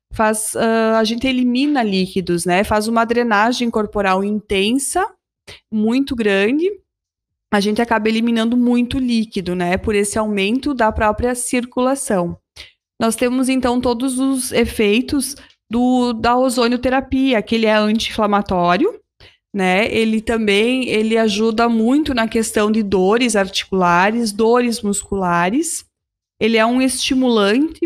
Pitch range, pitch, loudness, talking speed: 210-250 Hz, 225 Hz, -17 LUFS, 125 wpm